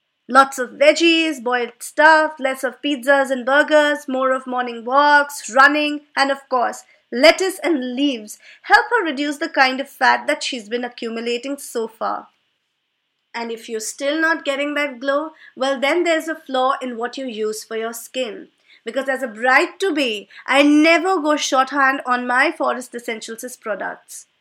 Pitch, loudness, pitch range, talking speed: 275 Hz, -18 LUFS, 250-295 Hz, 170 wpm